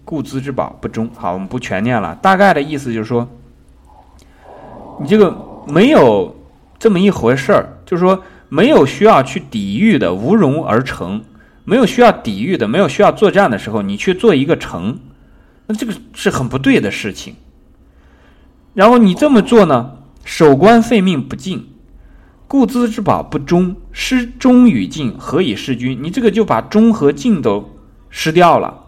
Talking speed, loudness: 245 characters per minute, -13 LUFS